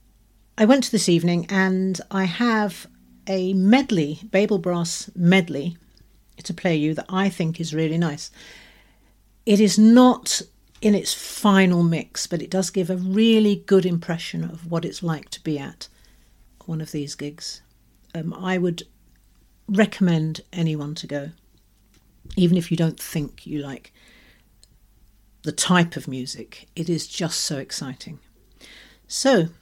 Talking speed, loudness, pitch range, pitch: 145 wpm, -21 LUFS, 150-190 Hz, 170 Hz